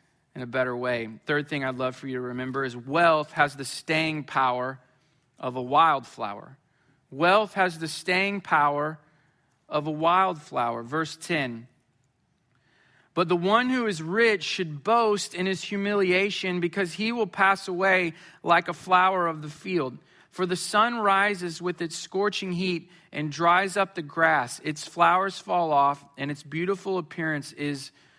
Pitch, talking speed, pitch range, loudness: 165 Hz, 160 wpm, 145-185 Hz, -25 LUFS